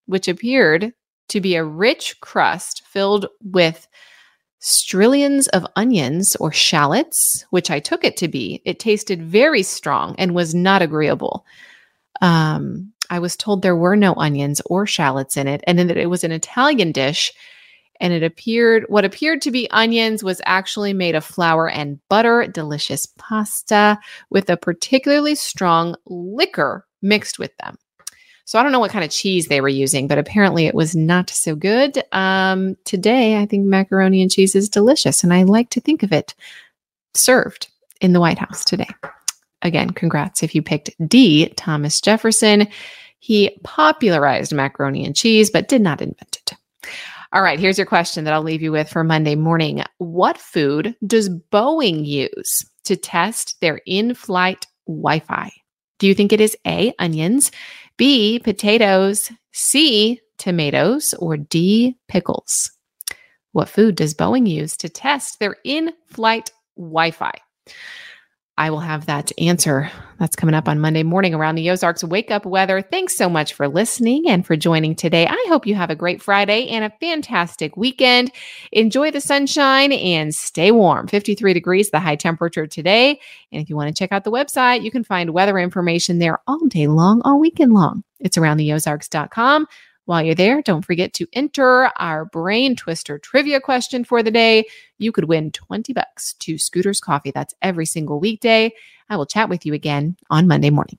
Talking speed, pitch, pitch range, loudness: 175 wpm, 190 Hz, 165-230 Hz, -17 LUFS